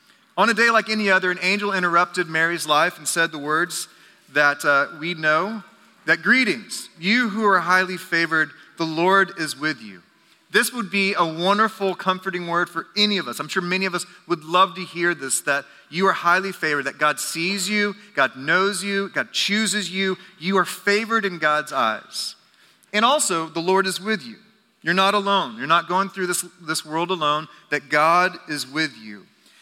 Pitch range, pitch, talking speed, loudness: 160-195 Hz, 180 Hz, 195 wpm, -21 LUFS